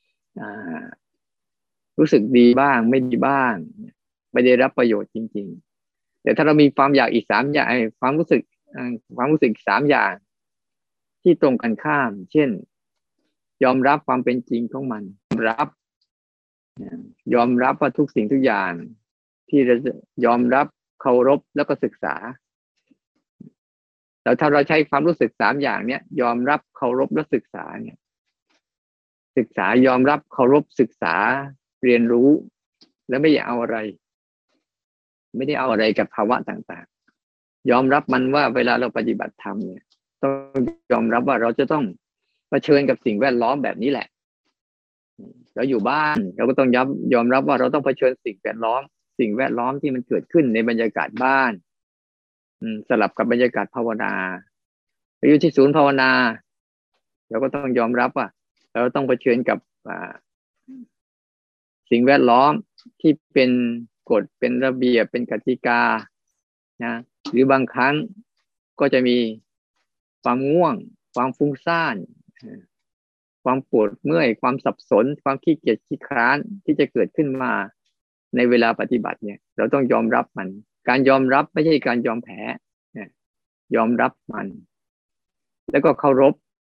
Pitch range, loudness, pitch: 120-145 Hz, -20 LUFS, 130 Hz